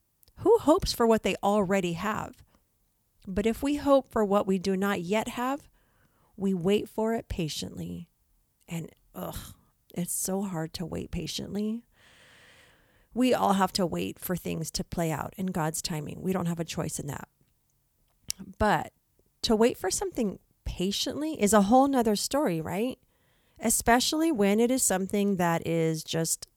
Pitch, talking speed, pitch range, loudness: 200 Hz, 160 wpm, 175-235 Hz, -28 LUFS